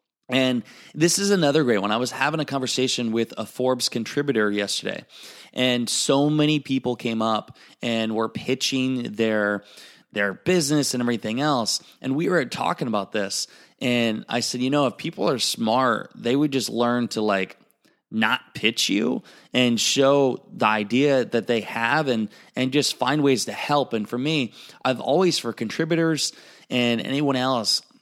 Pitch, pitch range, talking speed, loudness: 125 Hz, 115-140 Hz, 170 wpm, -23 LUFS